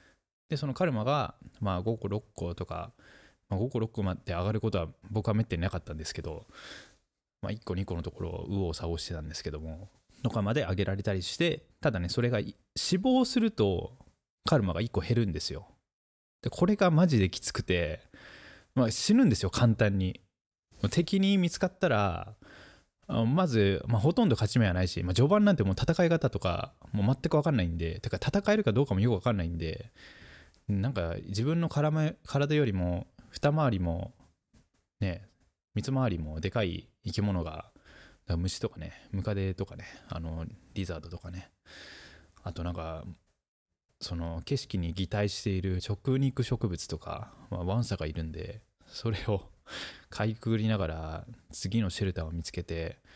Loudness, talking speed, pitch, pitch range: -30 LUFS, 320 characters per minute, 100 Hz, 90-120 Hz